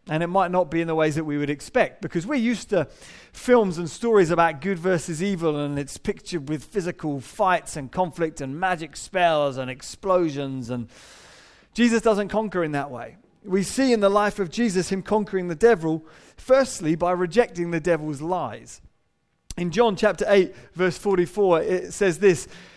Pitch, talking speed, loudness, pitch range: 180 Hz, 180 wpm, -23 LUFS, 160-200 Hz